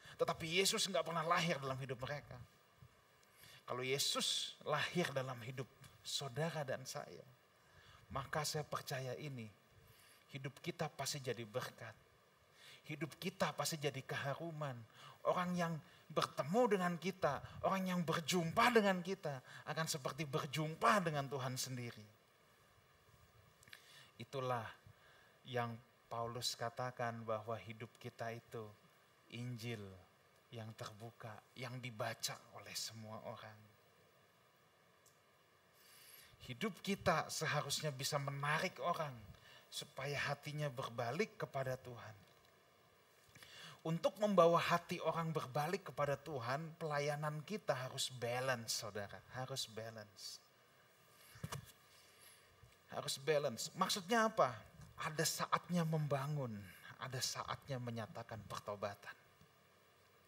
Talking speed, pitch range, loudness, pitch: 100 wpm, 120-160 Hz, -41 LUFS, 140 Hz